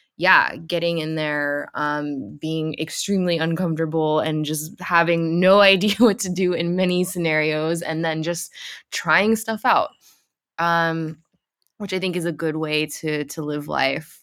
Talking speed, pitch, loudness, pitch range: 155 wpm, 165 Hz, -21 LUFS, 155-180 Hz